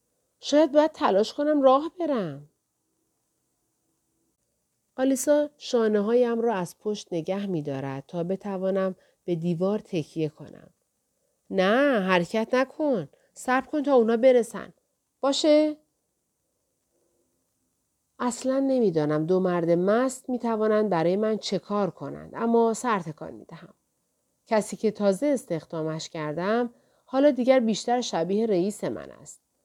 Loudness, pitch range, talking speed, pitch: -25 LUFS, 180-260 Hz, 115 wpm, 215 Hz